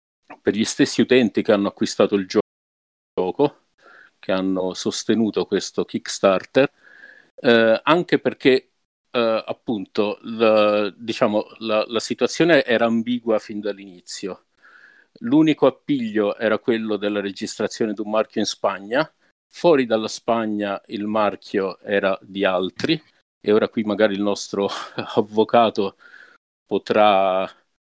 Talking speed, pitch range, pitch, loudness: 120 wpm, 100-115 Hz, 110 Hz, -21 LUFS